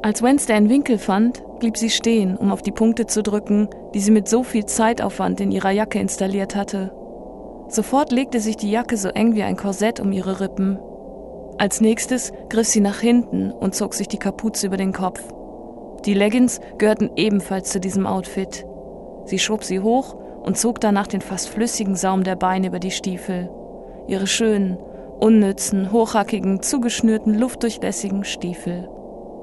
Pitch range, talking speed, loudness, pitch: 190-225 Hz, 165 wpm, -20 LUFS, 205 Hz